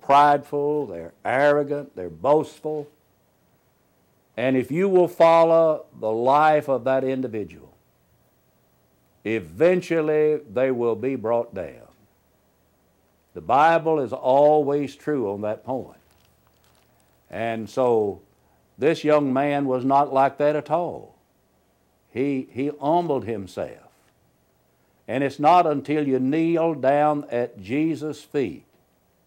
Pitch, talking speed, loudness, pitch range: 140 Hz, 115 wpm, -22 LUFS, 125-150 Hz